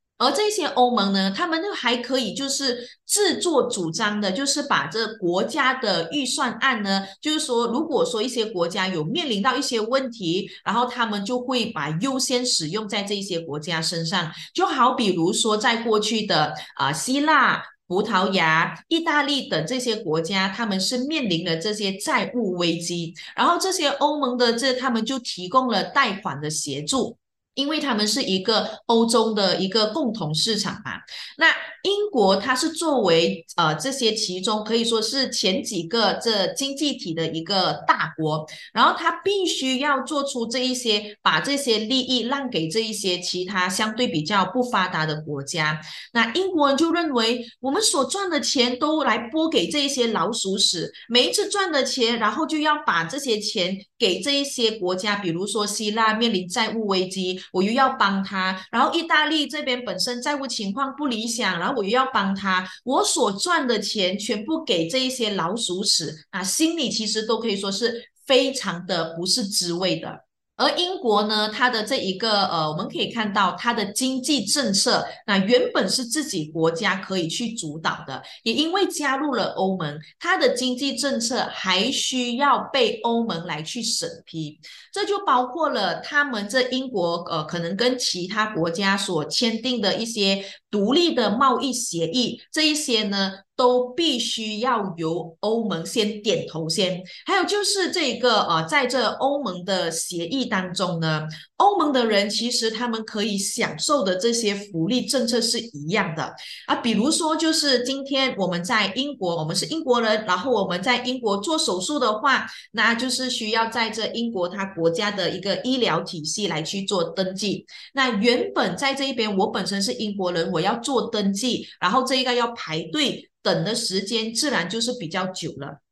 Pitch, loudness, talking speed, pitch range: 225 Hz, -22 LUFS, 265 characters per minute, 185-265 Hz